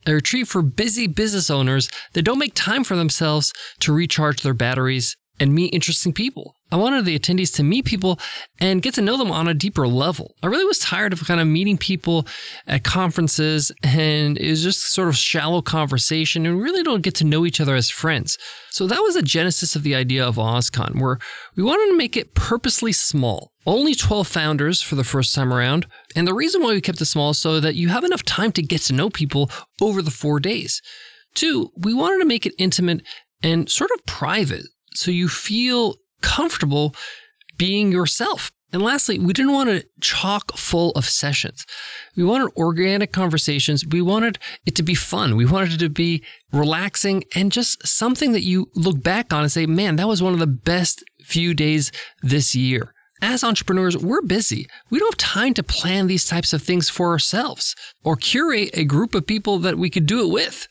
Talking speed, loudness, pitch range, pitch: 205 wpm, -19 LUFS, 155-210 Hz, 175 Hz